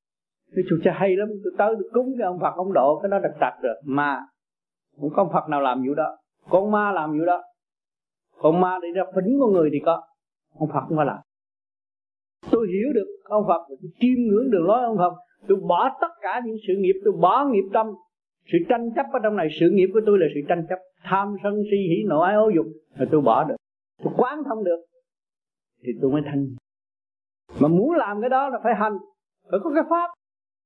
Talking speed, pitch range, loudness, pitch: 225 wpm, 155-220 Hz, -22 LUFS, 185 Hz